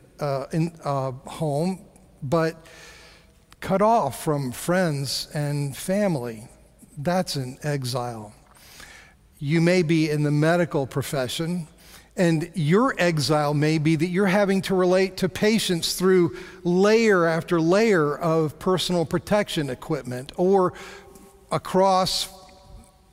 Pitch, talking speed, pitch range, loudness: 165 Hz, 110 wpm, 145-185 Hz, -23 LUFS